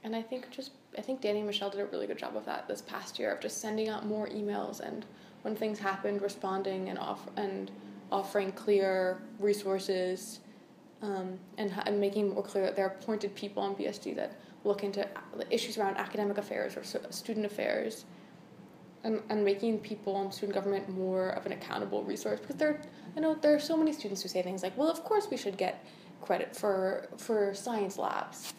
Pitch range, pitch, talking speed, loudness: 195-220 Hz, 205 Hz, 200 wpm, -34 LUFS